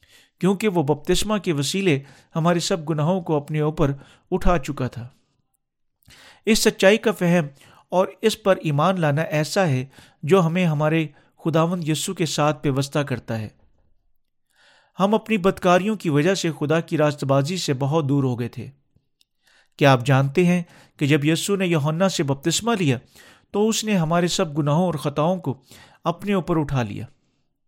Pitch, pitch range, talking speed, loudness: 160 Hz, 140-185 Hz, 165 wpm, -21 LUFS